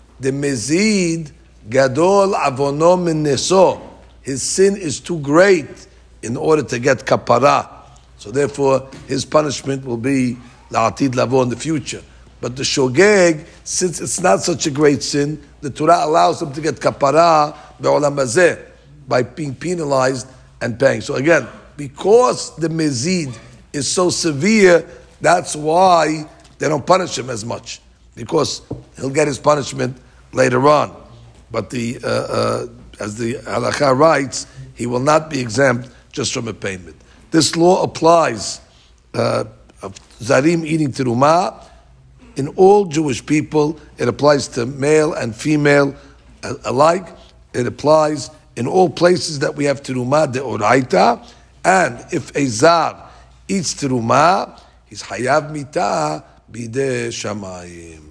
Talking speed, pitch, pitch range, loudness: 125 wpm, 140 Hz, 125-160 Hz, -16 LUFS